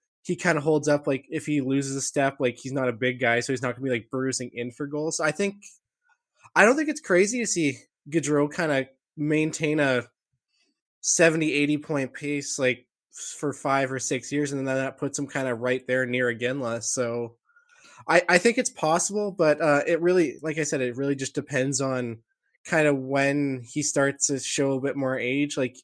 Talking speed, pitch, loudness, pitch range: 220 wpm, 140 Hz, -25 LUFS, 130-155 Hz